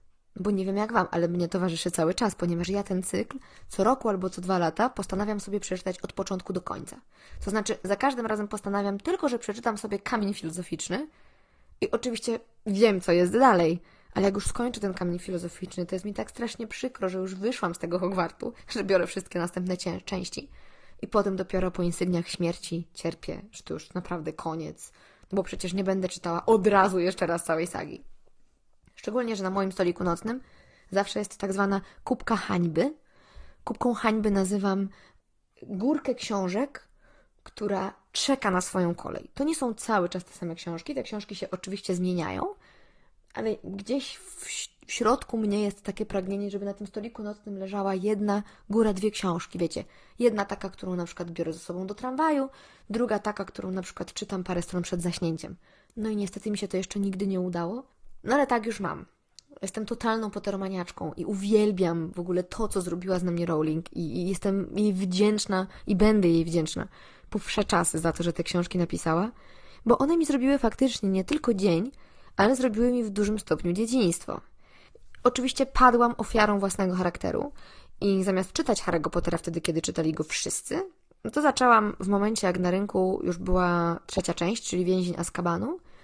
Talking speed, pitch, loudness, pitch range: 180 wpm, 195 Hz, -28 LUFS, 180-220 Hz